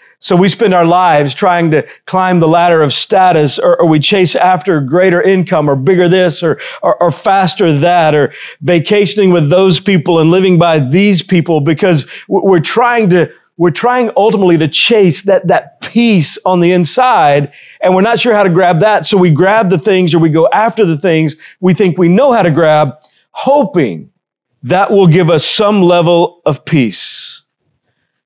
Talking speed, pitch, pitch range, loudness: 185 wpm, 180 Hz, 165-195 Hz, -9 LUFS